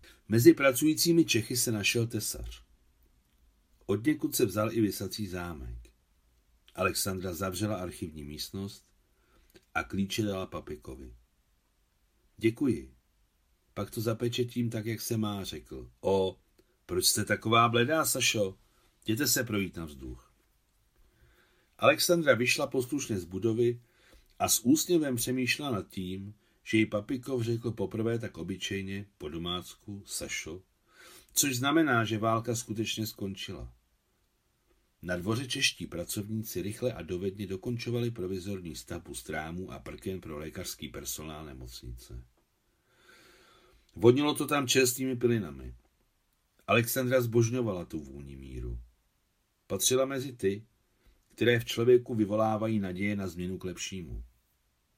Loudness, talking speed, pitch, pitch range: -30 LUFS, 115 wpm, 105 Hz, 85-120 Hz